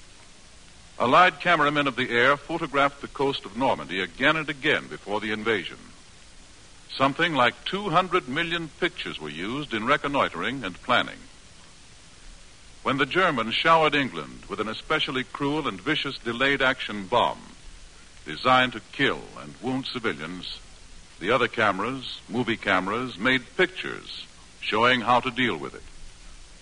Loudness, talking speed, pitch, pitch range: -24 LUFS, 135 wpm, 130 Hz, 105-150 Hz